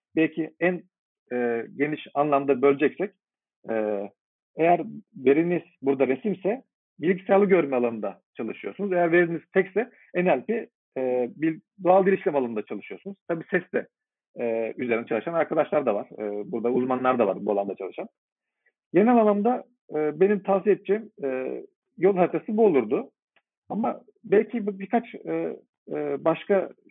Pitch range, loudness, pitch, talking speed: 130-195 Hz, -25 LUFS, 170 Hz, 130 wpm